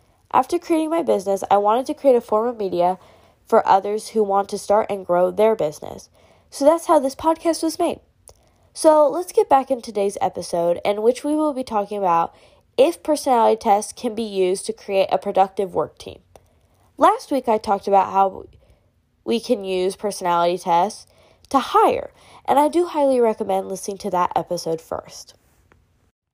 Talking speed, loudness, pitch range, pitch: 180 wpm, -20 LUFS, 190-275 Hz, 210 Hz